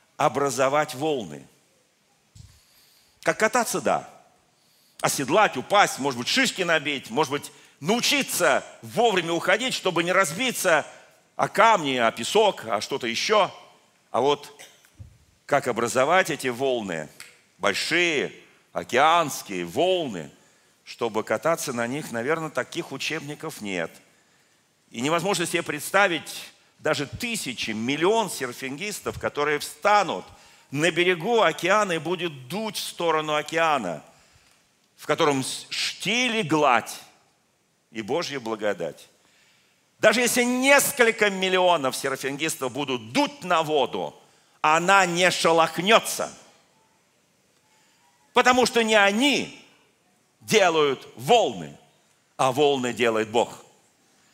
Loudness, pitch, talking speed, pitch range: -23 LUFS, 160 Hz, 100 wpm, 135-200 Hz